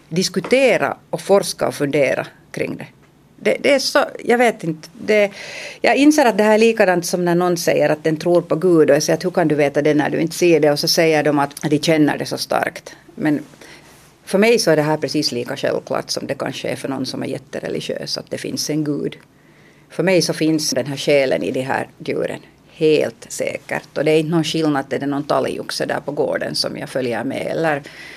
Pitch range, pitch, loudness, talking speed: 150-190 Hz, 165 Hz, -18 LUFS, 235 wpm